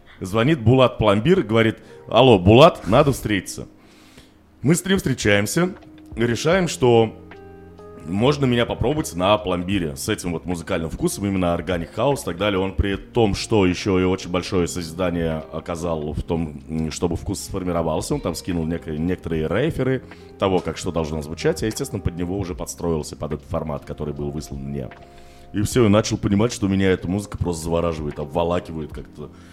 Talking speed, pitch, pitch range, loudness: 165 wpm, 90 Hz, 80-105 Hz, -21 LUFS